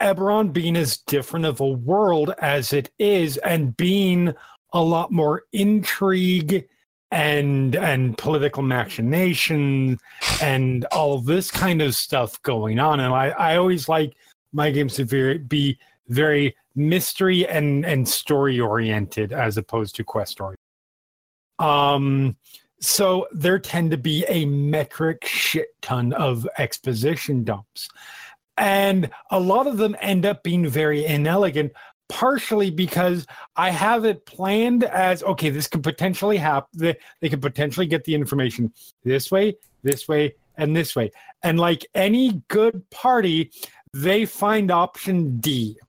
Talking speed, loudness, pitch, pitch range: 140 wpm, -21 LUFS, 155 Hz, 135-185 Hz